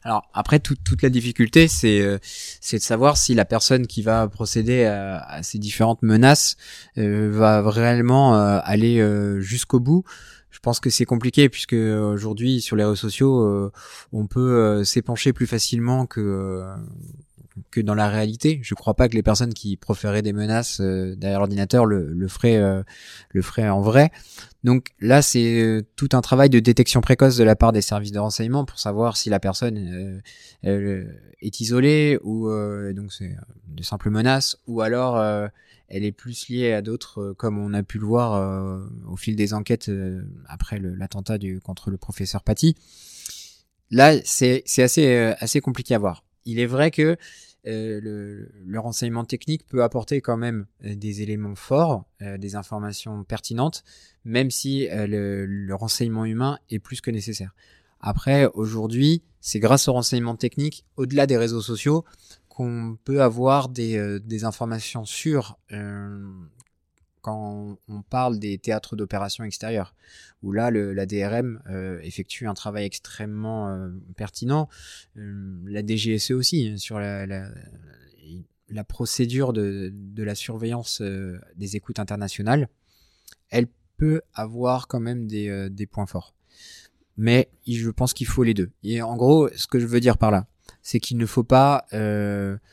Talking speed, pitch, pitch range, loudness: 170 wpm, 110 Hz, 100-125 Hz, -21 LUFS